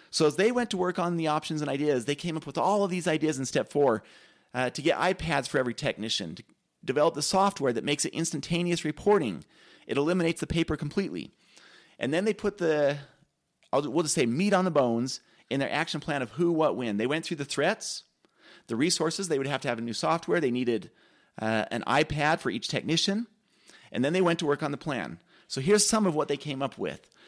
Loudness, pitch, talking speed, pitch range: -28 LUFS, 155 Hz, 230 wpm, 140-175 Hz